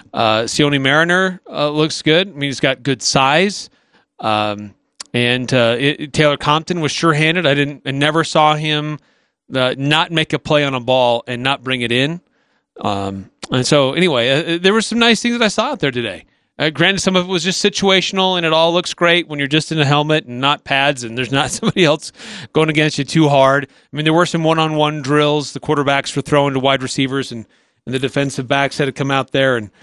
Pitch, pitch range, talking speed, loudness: 145 Hz, 135-160 Hz, 225 wpm, -15 LUFS